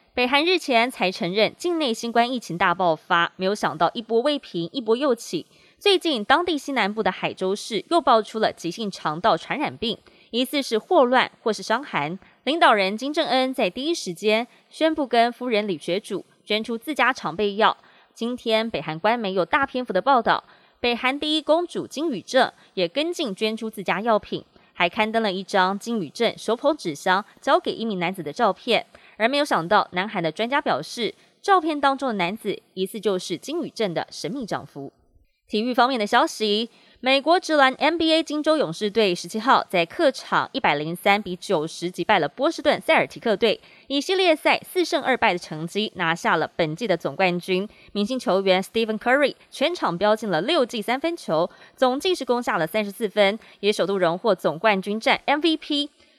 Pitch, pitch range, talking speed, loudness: 225 Hz, 190-275 Hz, 300 characters per minute, -22 LUFS